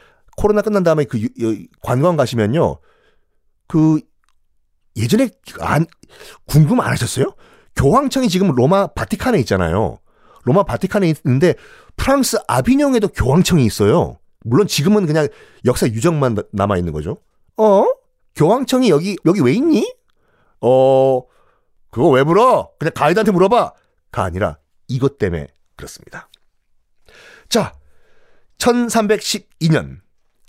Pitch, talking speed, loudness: 155 Hz, 255 characters per minute, -16 LUFS